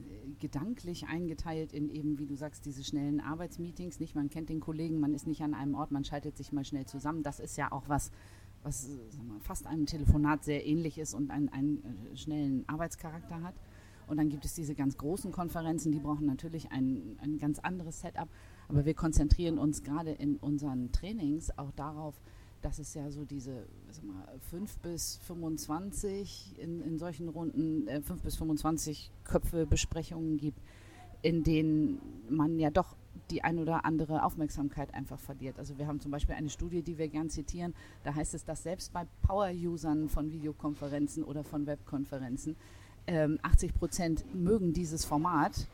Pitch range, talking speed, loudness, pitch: 140-160 Hz, 175 wpm, -36 LUFS, 150 Hz